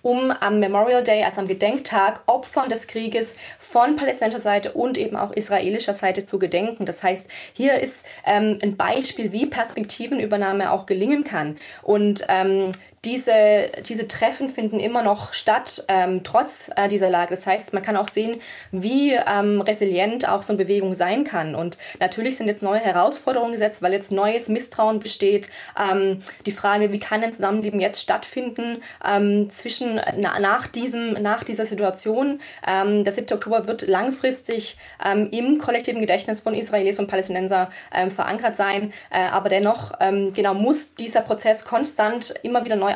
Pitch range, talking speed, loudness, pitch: 195-235 Hz, 165 wpm, -21 LUFS, 210 Hz